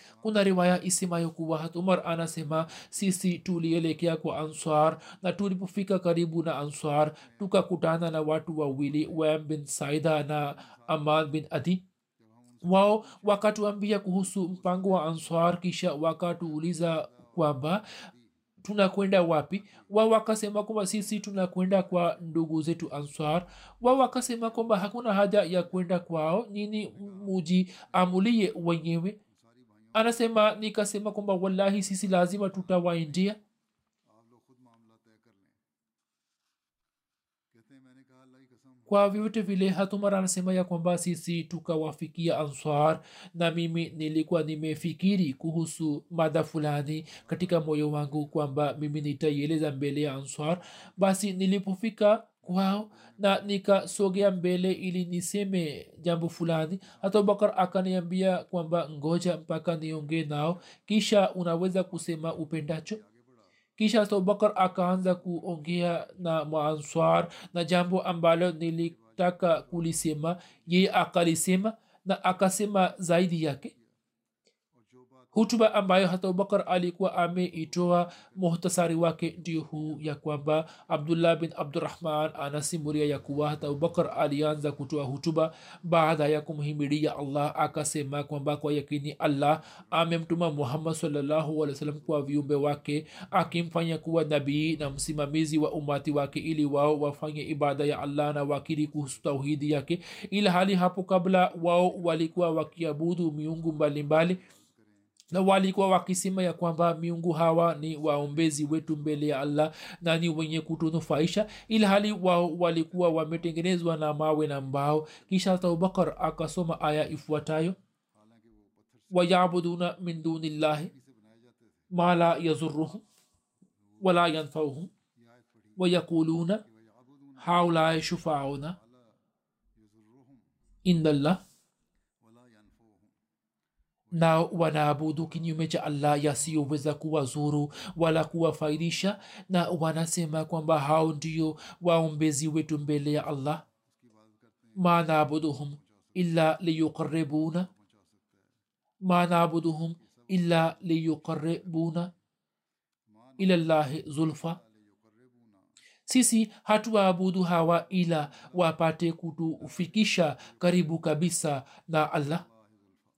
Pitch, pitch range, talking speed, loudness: 165 Hz, 150-185 Hz, 85 wpm, -28 LUFS